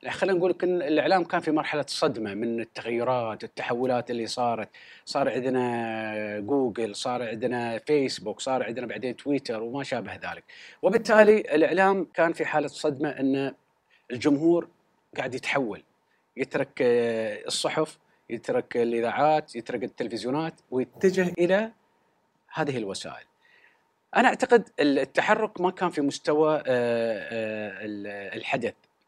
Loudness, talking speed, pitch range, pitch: -26 LUFS, 110 wpm, 120-180 Hz, 145 Hz